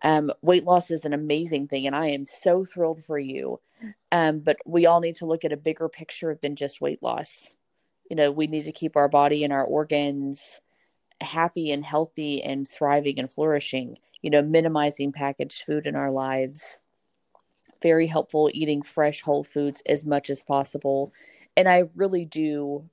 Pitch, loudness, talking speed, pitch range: 150 Hz, -24 LUFS, 180 wpm, 145-160 Hz